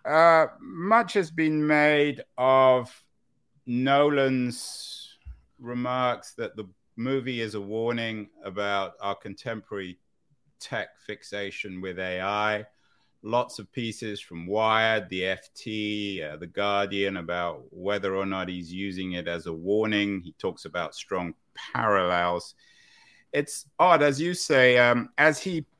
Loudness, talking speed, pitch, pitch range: -26 LUFS, 125 wpm, 110 Hz, 100-135 Hz